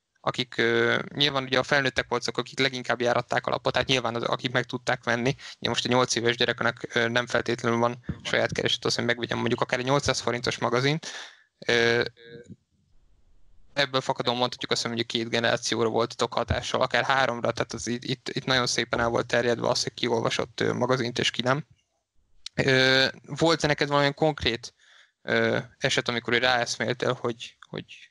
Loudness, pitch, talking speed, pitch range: -25 LUFS, 120 Hz, 170 wpm, 115-130 Hz